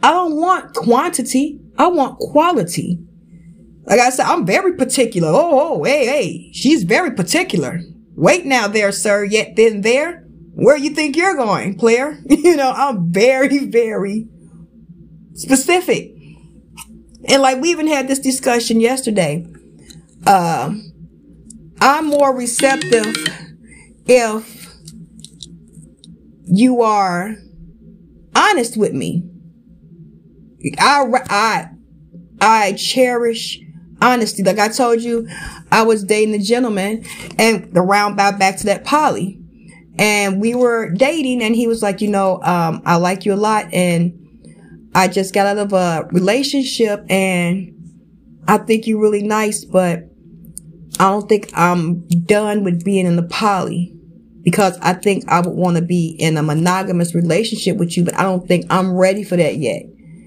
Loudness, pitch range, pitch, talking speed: -15 LUFS, 175-240 Hz, 205 Hz, 140 wpm